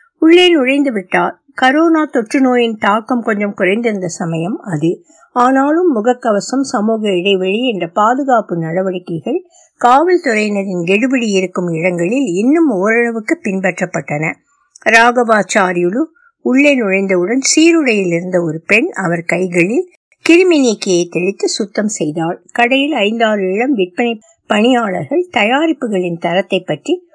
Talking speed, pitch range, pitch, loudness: 85 wpm, 185-280 Hz, 225 Hz, -13 LUFS